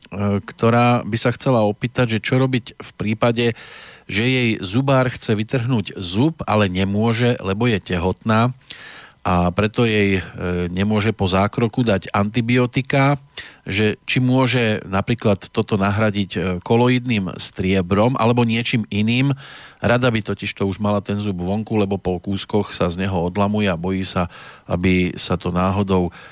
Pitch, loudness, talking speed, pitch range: 105 Hz, -19 LUFS, 145 wpm, 95-120 Hz